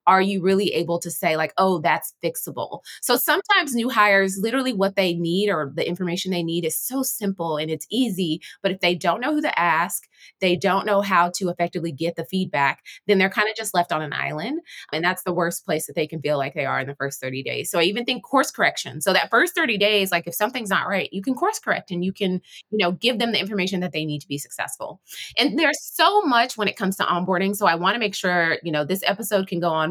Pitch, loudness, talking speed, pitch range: 185 Hz, -22 LUFS, 260 wpm, 170-210 Hz